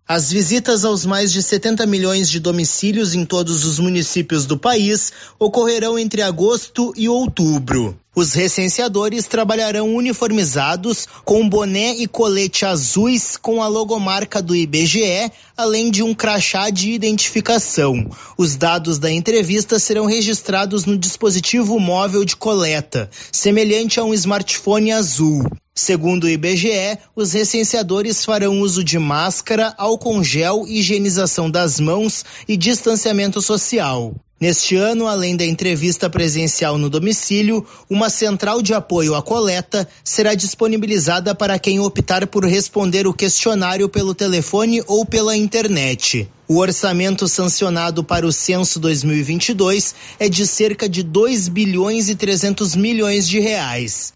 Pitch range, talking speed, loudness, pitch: 175-215 Hz, 130 wpm, -16 LUFS, 200 Hz